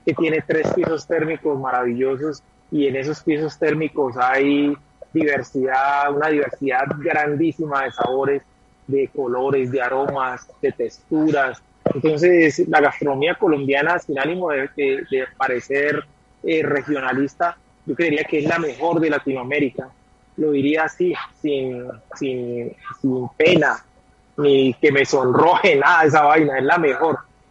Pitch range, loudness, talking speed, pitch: 135-160 Hz, -19 LUFS, 135 wpm, 145 Hz